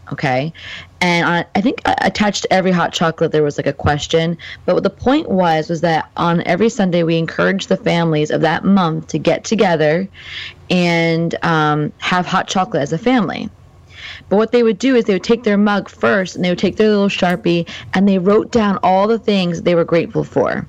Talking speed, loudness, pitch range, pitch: 210 wpm, -16 LUFS, 165-200 Hz, 175 Hz